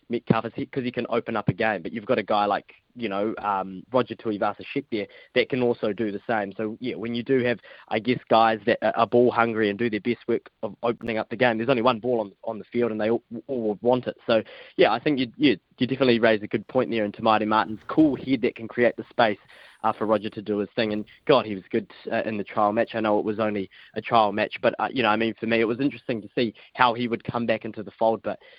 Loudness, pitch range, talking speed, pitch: -25 LUFS, 110-120 Hz, 280 wpm, 115 Hz